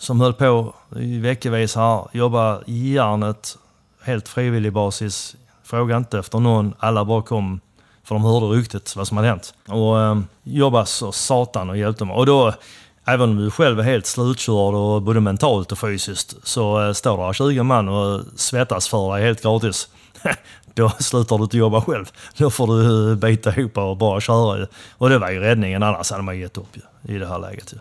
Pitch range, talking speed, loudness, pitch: 105-120 Hz, 185 wpm, -19 LUFS, 110 Hz